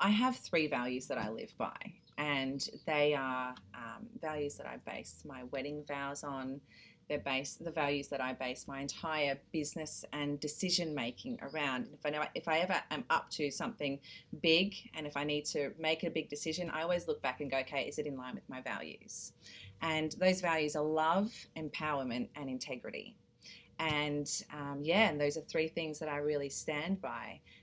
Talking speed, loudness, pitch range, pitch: 195 wpm, -36 LUFS, 140-160 Hz, 150 Hz